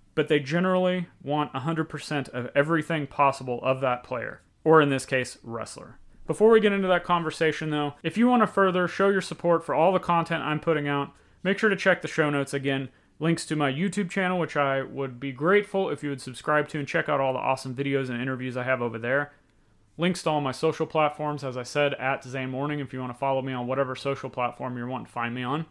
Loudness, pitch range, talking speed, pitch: -26 LUFS, 130-165 Hz, 240 wpm, 145 Hz